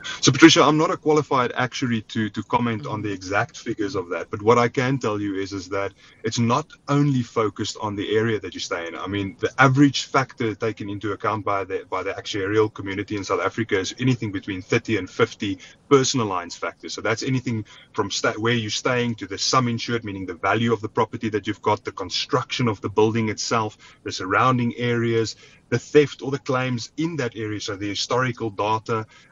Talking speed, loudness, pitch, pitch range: 215 wpm, -23 LUFS, 115 Hz, 105-130 Hz